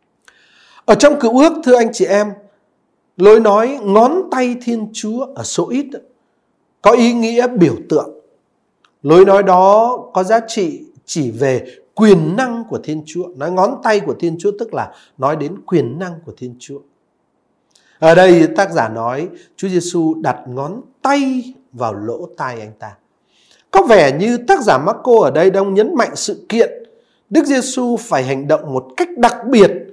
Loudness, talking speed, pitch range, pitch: -14 LUFS, 175 wpm, 180-255 Hz, 215 Hz